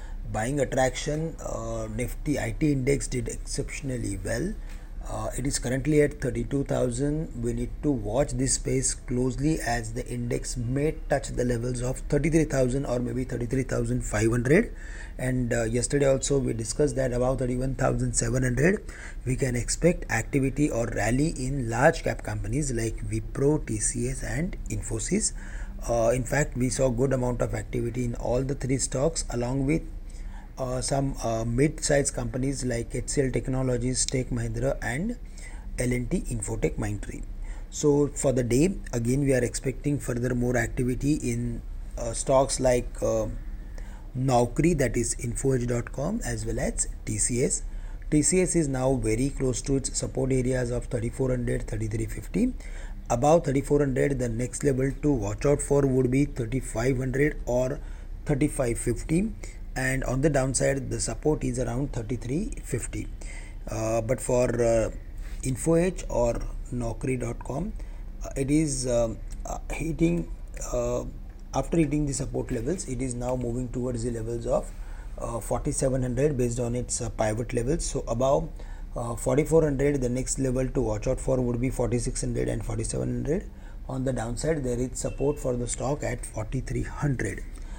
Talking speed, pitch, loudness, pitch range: 140 wpm, 125 Hz, -27 LUFS, 120-140 Hz